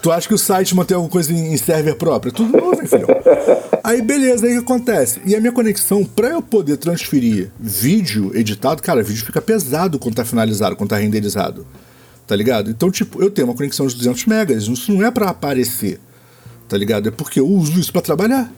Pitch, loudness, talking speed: 175 Hz, -16 LUFS, 215 wpm